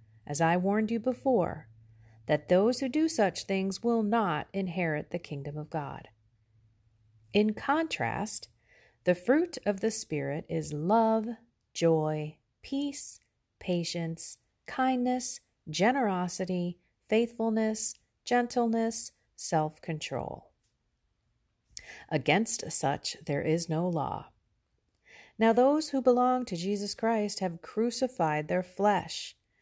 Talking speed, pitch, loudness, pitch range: 105 wpm, 195 Hz, -30 LUFS, 155-230 Hz